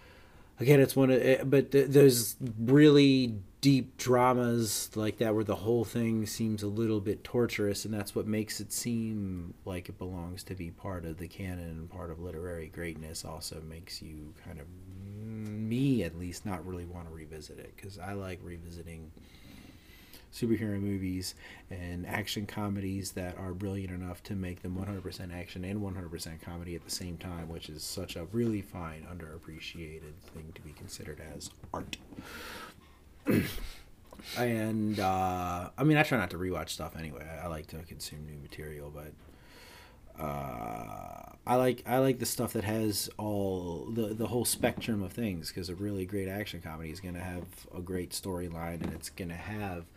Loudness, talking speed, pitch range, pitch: -32 LUFS, 180 wpm, 85-110 Hz, 95 Hz